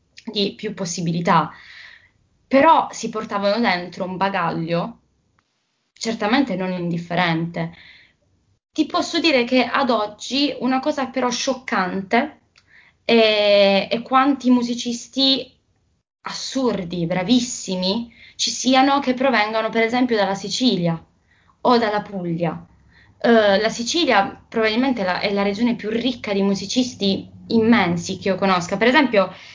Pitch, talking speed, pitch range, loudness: 220 Hz, 120 wpm, 190-250 Hz, -19 LUFS